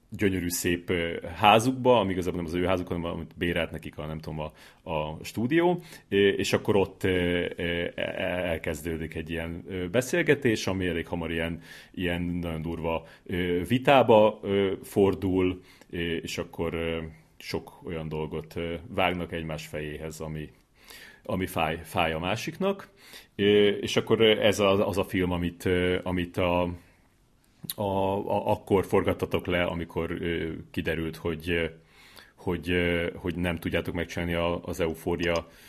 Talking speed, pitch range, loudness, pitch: 130 wpm, 85-95 Hz, -27 LUFS, 90 Hz